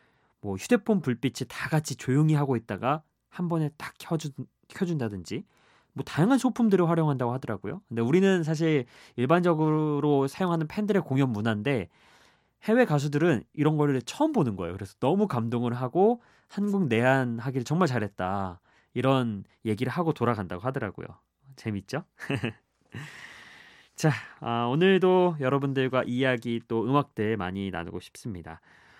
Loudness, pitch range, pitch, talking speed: -27 LUFS, 115-160 Hz, 135 Hz, 325 characters per minute